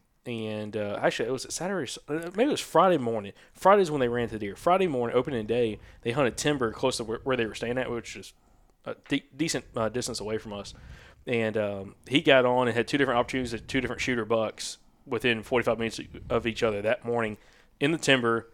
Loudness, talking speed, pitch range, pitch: -27 LUFS, 220 wpm, 110-130 Hz, 120 Hz